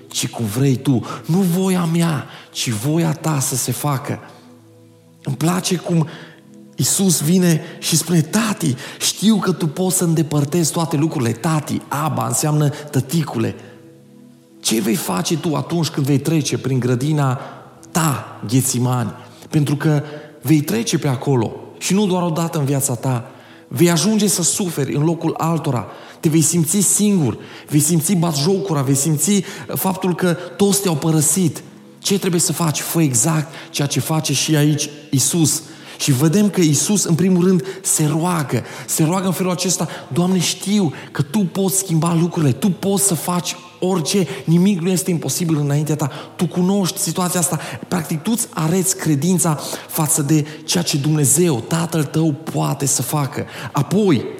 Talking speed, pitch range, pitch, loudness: 160 wpm, 145-180 Hz, 160 Hz, -18 LUFS